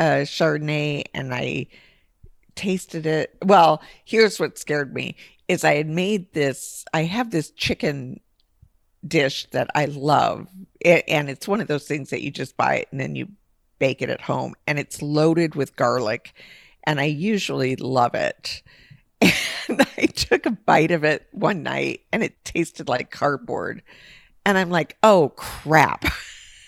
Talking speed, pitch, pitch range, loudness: 160 wpm, 150 Hz, 140-175 Hz, -22 LUFS